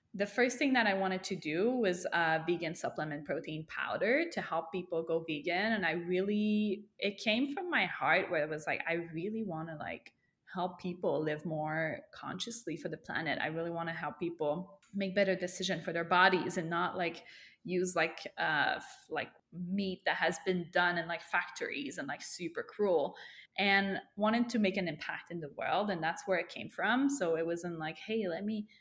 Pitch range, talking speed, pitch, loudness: 165-200 Hz, 205 wpm, 180 Hz, -34 LUFS